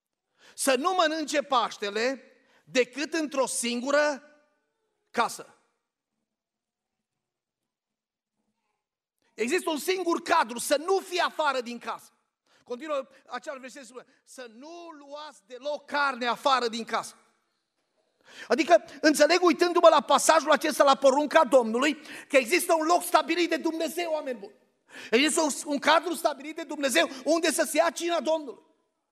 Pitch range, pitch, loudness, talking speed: 265-330 Hz, 295 Hz, -25 LUFS, 120 wpm